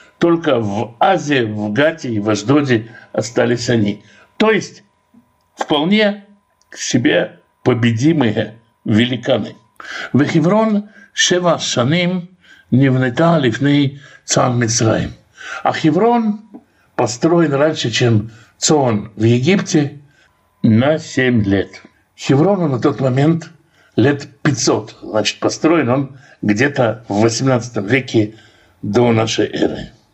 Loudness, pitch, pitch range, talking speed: -16 LUFS, 135 Hz, 115-165 Hz, 105 wpm